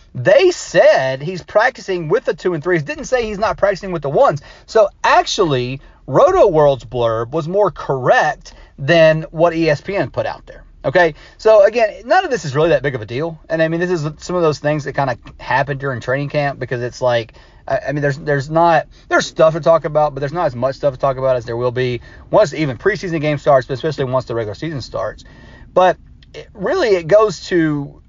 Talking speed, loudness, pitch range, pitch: 220 wpm, -16 LUFS, 135-180 Hz, 155 Hz